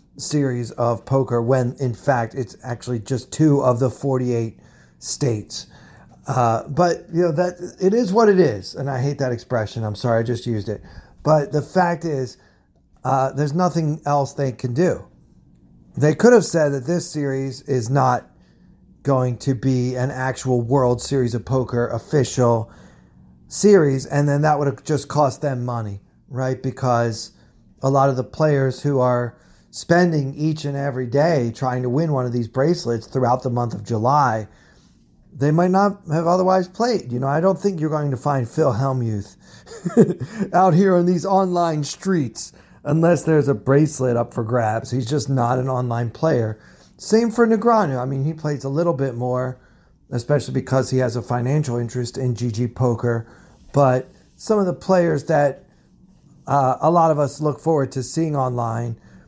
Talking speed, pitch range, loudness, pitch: 175 wpm, 120-155 Hz, -20 LUFS, 135 Hz